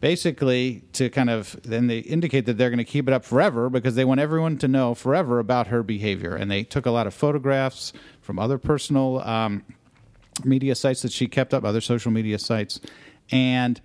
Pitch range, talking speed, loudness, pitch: 115-135 Hz, 205 wpm, -23 LUFS, 125 Hz